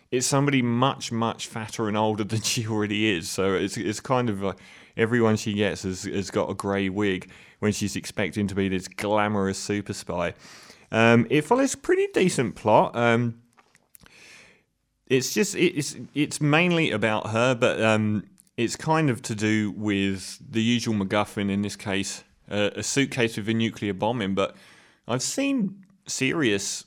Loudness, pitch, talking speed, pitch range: -25 LUFS, 110 Hz, 170 wpm, 100-130 Hz